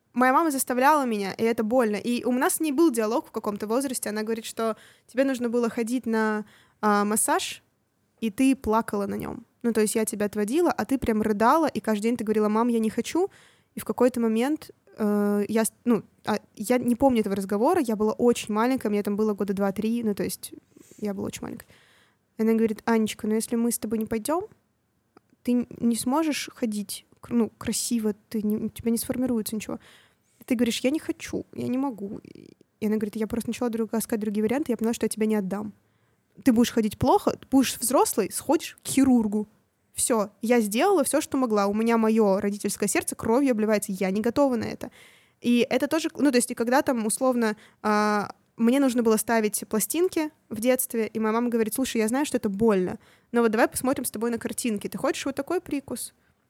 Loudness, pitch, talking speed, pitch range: -25 LUFS, 230 Hz, 210 wpm, 215-255 Hz